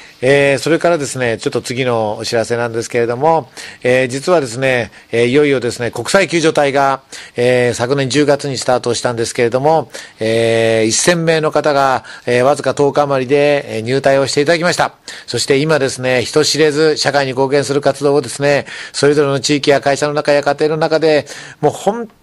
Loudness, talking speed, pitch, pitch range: -14 LUFS, 380 characters per minute, 140 Hz, 120-150 Hz